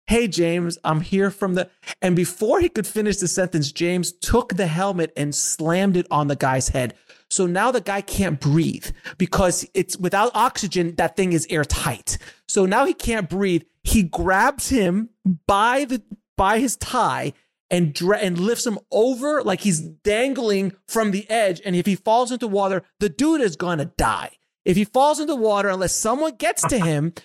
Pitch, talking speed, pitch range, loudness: 195 Hz, 185 wpm, 175-220 Hz, -21 LUFS